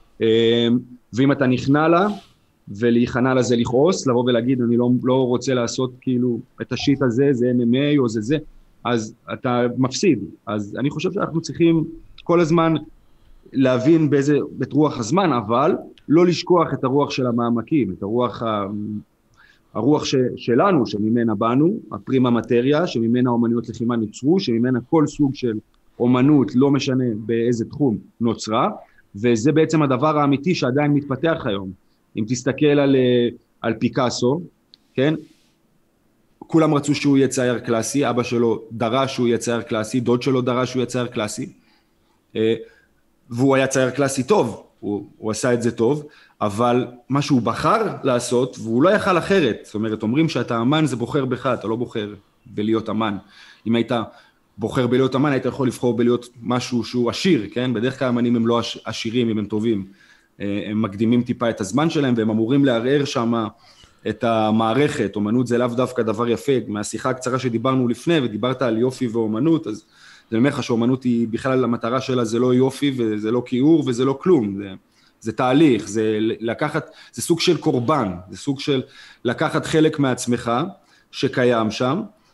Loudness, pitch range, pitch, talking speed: -20 LUFS, 115-140 Hz, 125 Hz, 160 wpm